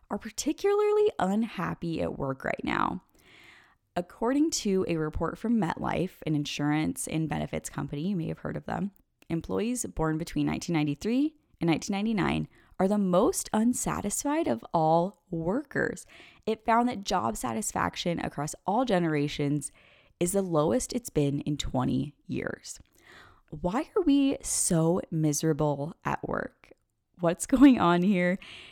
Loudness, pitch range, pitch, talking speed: -28 LUFS, 155-225 Hz, 175 Hz, 135 wpm